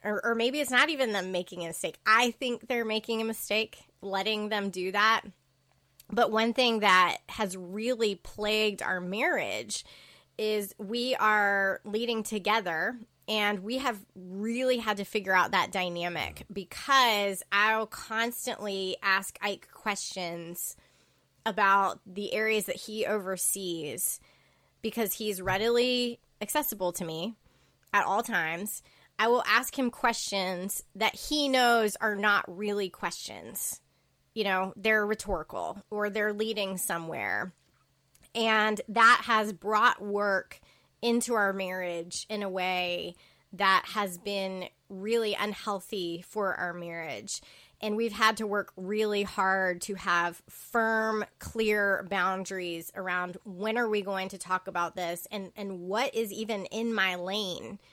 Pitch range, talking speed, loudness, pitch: 190-220 Hz, 140 wpm, -29 LUFS, 205 Hz